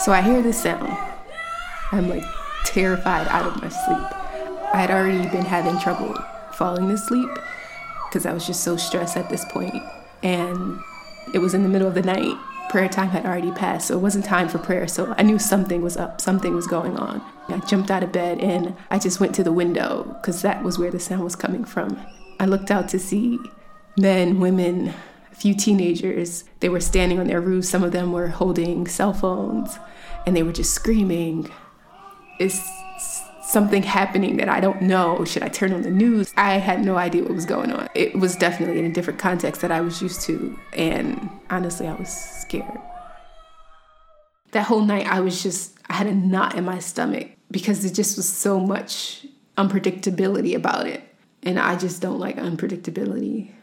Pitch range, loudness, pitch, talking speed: 180-210 Hz, -22 LUFS, 190 Hz, 195 wpm